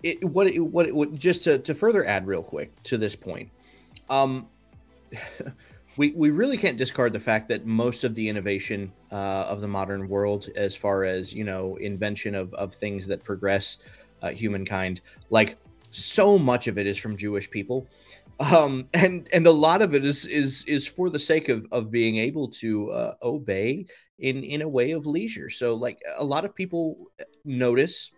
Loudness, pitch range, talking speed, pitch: -24 LUFS, 100-150 Hz, 185 wpm, 120 Hz